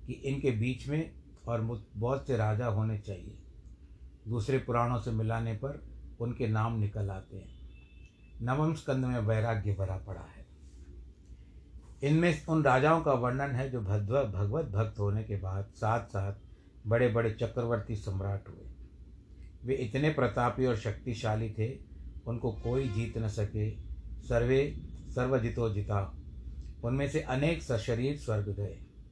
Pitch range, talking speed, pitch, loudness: 95-125 Hz, 140 wpm, 110 Hz, -32 LUFS